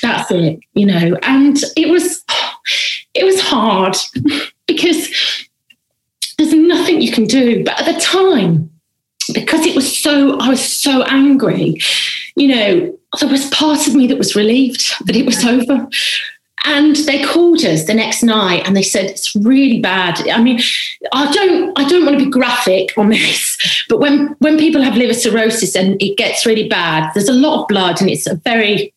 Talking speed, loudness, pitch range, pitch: 180 wpm, -12 LUFS, 215-305 Hz, 265 Hz